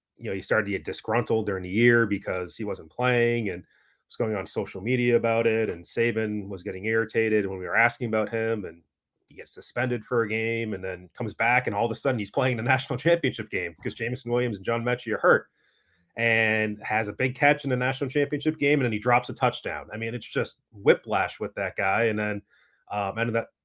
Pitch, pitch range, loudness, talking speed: 115 Hz, 105-125 Hz, -26 LUFS, 235 wpm